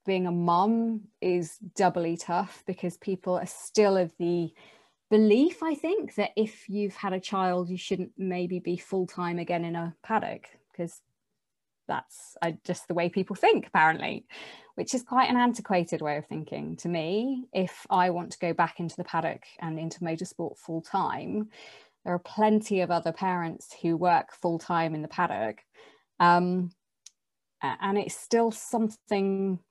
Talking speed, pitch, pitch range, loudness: 165 wpm, 180 Hz, 170-205 Hz, -28 LUFS